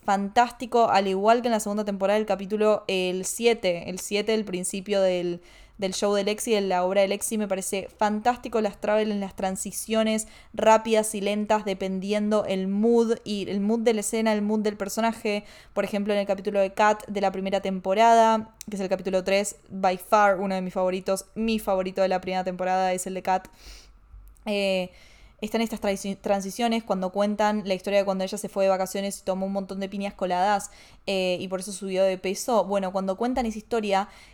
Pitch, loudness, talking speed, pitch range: 200 Hz, -25 LUFS, 205 wpm, 190-215 Hz